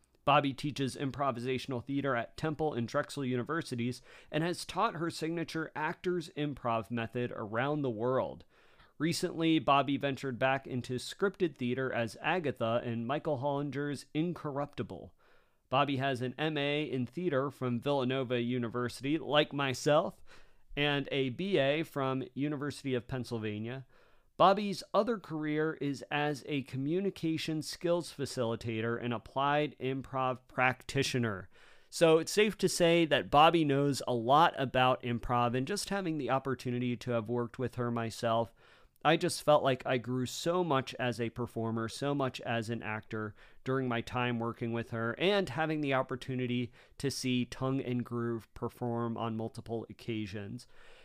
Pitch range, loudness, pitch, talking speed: 120-150 Hz, -33 LUFS, 130 Hz, 145 wpm